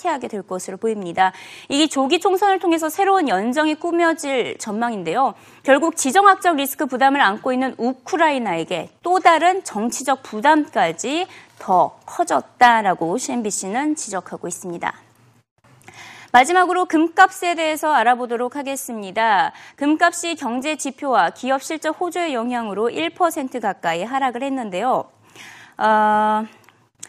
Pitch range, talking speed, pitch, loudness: 225-335 Hz, 305 characters per minute, 275 Hz, -19 LUFS